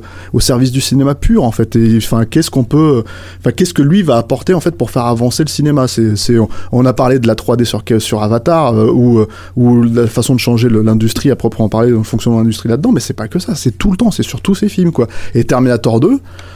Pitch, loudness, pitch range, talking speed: 120 Hz, -12 LUFS, 115-135 Hz, 270 wpm